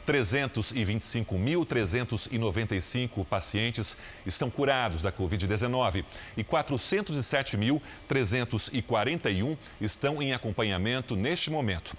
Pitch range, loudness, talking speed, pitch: 100-135 Hz, -29 LUFS, 65 wpm, 115 Hz